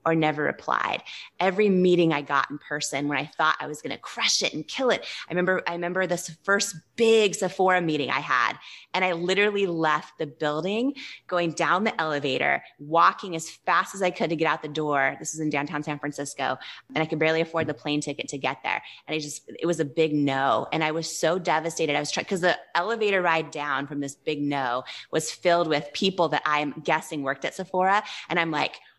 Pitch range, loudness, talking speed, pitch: 150-180 Hz, -25 LUFS, 225 wpm, 160 Hz